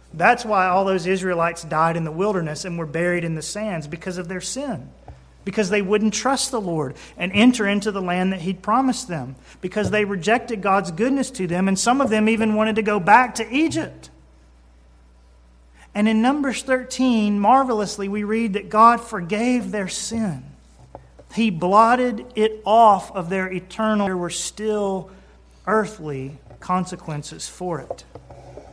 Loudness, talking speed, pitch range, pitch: -20 LUFS, 165 wpm, 175-220 Hz, 200 Hz